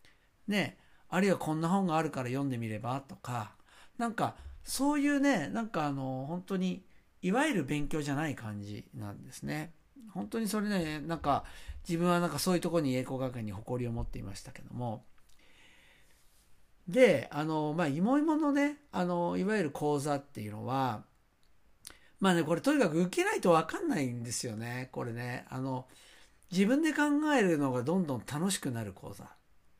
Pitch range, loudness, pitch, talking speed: 120-190 Hz, -32 LUFS, 150 Hz, 340 characters per minute